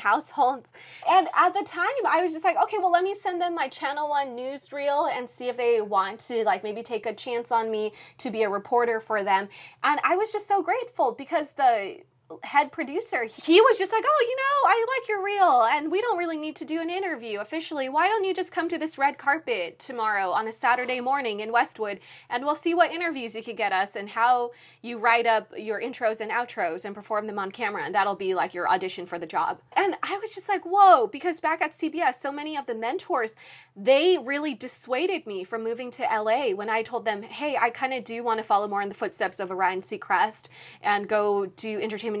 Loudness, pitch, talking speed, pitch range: -25 LUFS, 265 Hz, 230 wpm, 220-350 Hz